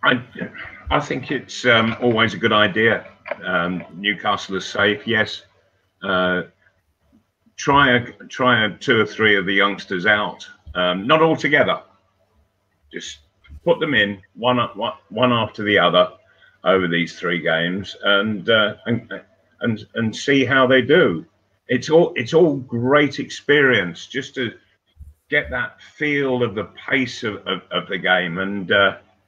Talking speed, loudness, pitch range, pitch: 150 wpm, -19 LUFS, 95-125 Hz, 105 Hz